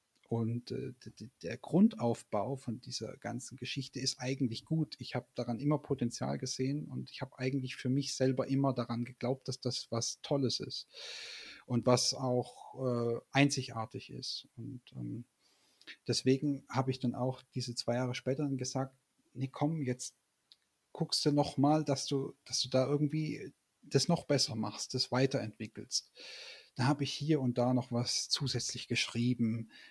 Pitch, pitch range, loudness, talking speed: 130 Hz, 120-140 Hz, -35 LUFS, 160 wpm